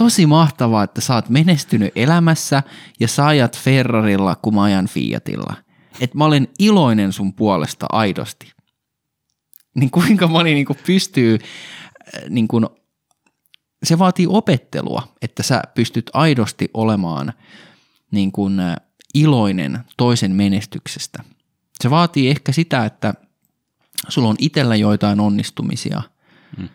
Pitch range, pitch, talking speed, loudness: 105-155 Hz, 125 Hz, 100 wpm, -17 LUFS